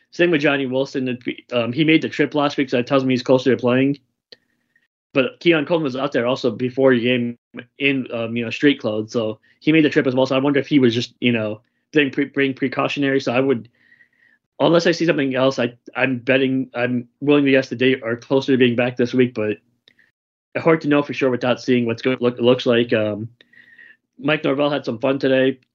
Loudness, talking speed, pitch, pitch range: -19 LUFS, 235 wpm, 130 Hz, 120-140 Hz